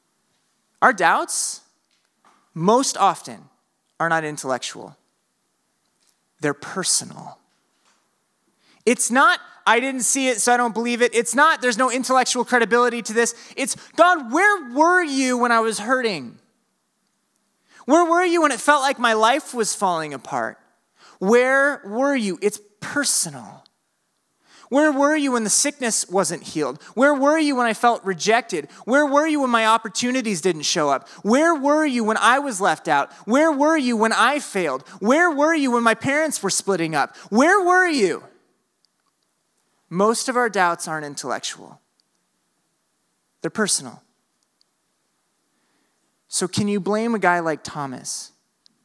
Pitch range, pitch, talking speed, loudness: 200-285 Hz, 240 Hz, 145 wpm, -19 LUFS